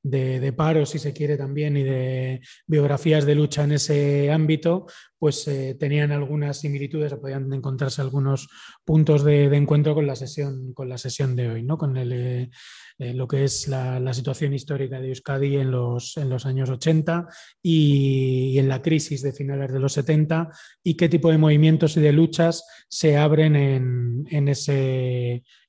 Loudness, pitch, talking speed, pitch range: -22 LUFS, 140 Hz, 180 wpm, 130-155 Hz